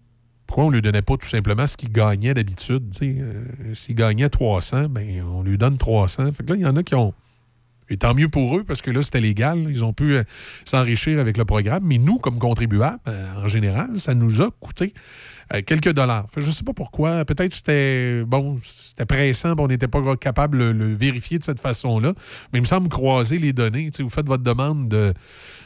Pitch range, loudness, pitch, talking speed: 115-145 Hz, -20 LUFS, 130 Hz, 225 wpm